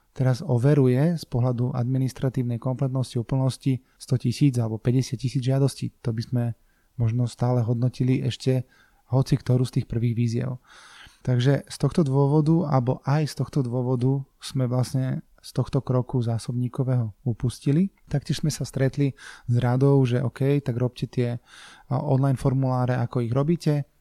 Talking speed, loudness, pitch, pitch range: 145 wpm, -25 LUFS, 130 Hz, 125-140 Hz